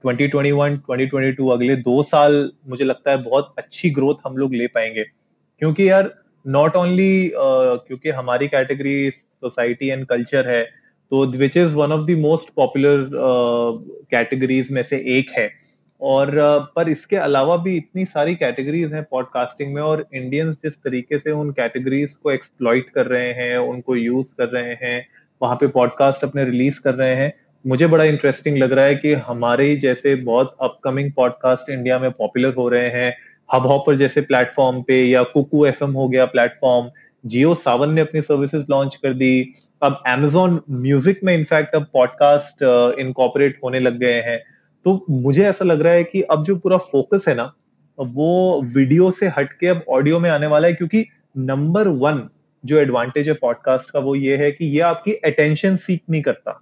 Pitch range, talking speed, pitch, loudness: 130-155 Hz, 180 wpm, 140 Hz, -18 LUFS